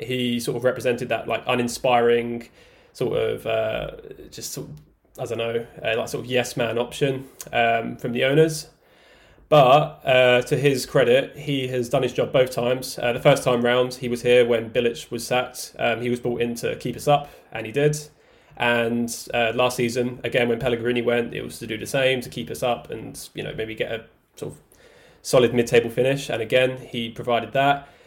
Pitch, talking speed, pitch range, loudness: 125 Hz, 210 wpm, 120-135 Hz, -22 LUFS